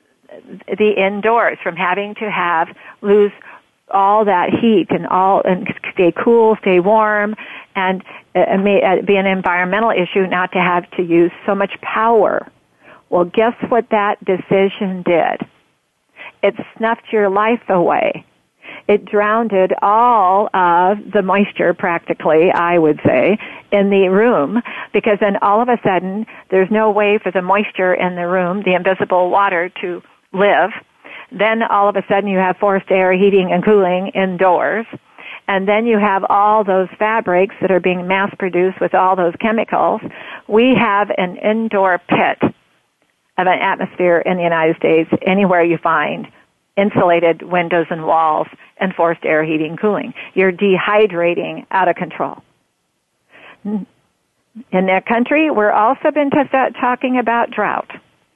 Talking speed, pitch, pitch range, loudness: 150 wpm, 195 Hz, 180-215 Hz, -15 LUFS